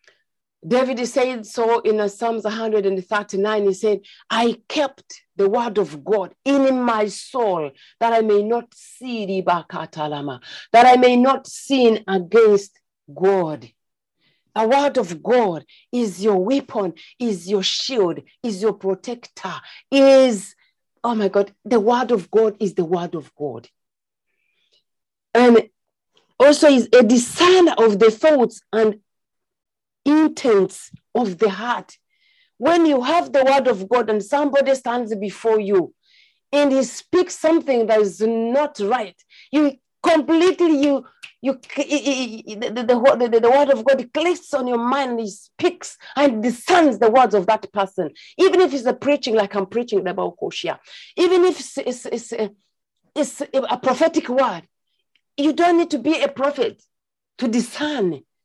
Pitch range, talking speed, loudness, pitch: 210-275 Hz, 145 wpm, -18 LUFS, 235 Hz